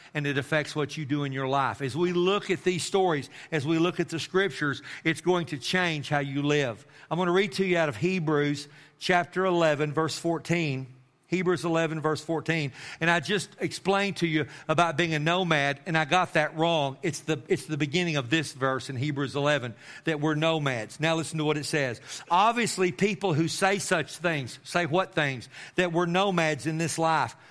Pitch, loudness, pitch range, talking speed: 160 Hz, -27 LUFS, 145-175 Hz, 205 wpm